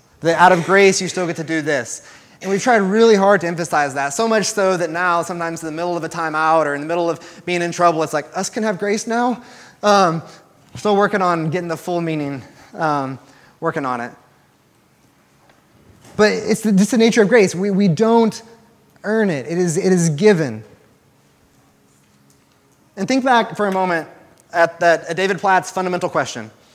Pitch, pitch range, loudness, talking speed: 175 Hz, 160-205 Hz, -17 LUFS, 195 wpm